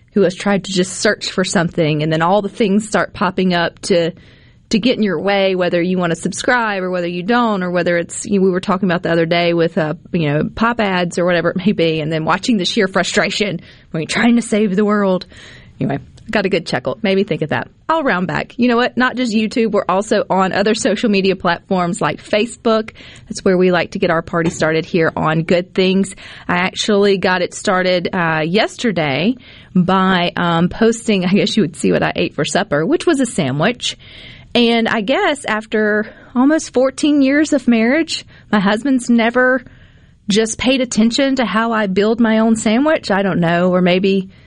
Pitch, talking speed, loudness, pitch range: 200 Hz, 215 wpm, -16 LUFS, 175-225 Hz